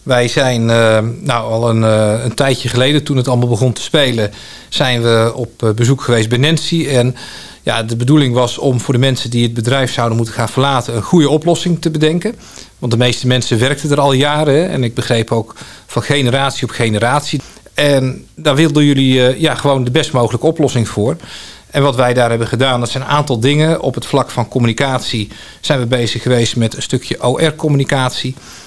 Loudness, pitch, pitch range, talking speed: -13 LUFS, 130 Hz, 120-145 Hz, 195 wpm